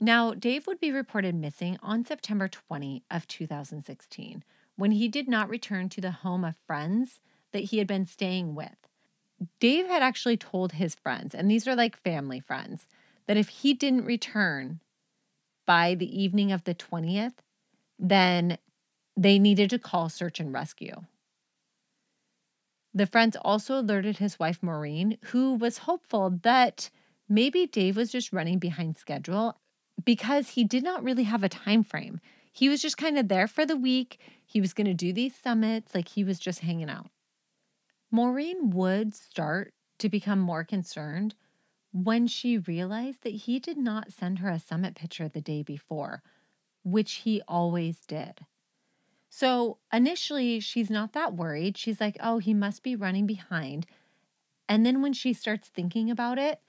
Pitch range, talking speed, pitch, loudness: 180-235 Hz, 165 wpm, 205 Hz, -28 LUFS